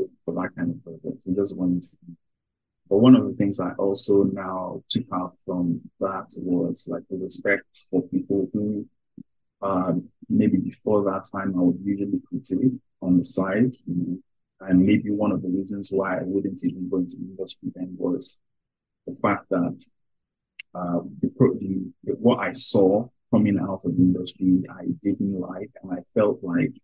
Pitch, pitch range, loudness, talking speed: 95 Hz, 90-100 Hz, -24 LUFS, 175 wpm